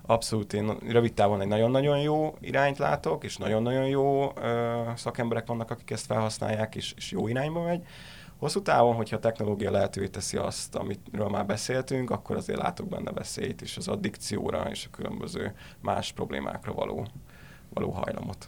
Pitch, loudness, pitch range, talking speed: 115 Hz, -29 LUFS, 110-135 Hz, 160 wpm